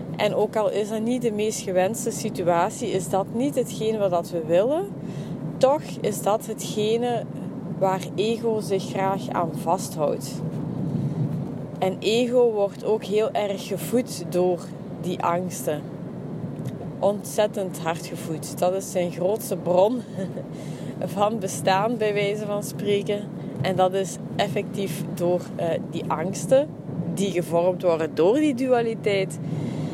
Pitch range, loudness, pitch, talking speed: 175-210 Hz, -25 LUFS, 190 Hz, 130 wpm